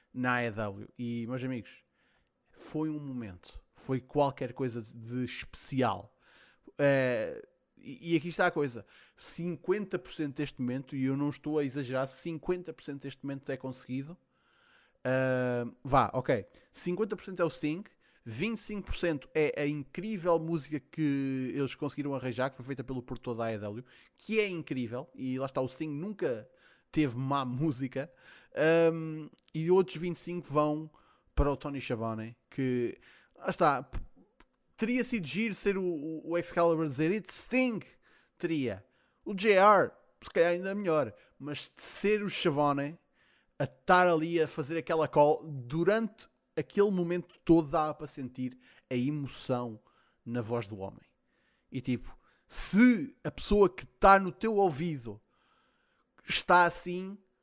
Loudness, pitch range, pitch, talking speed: -31 LUFS, 130-175 Hz, 150 Hz, 145 wpm